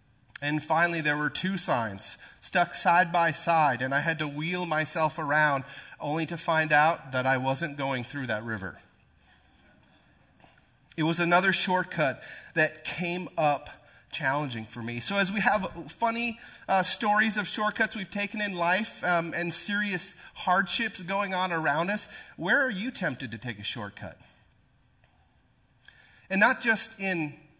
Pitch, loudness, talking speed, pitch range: 165 Hz, -27 LUFS, 155 wpm, 140-190 Hz